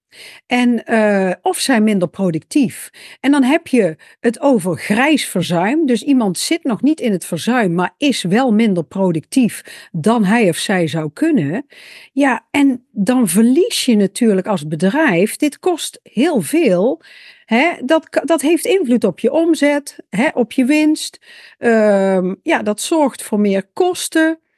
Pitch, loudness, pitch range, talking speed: 245 Hz, -15 LUFS, 205-310 Hz, 155 wpm